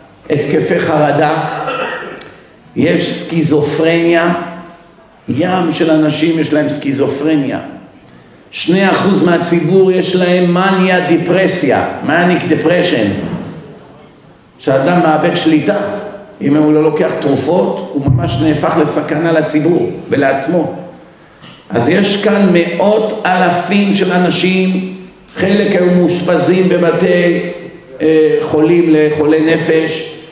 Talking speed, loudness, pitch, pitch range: 95 wpm, -12 LUFS, 170 Hz, 155-185 Hz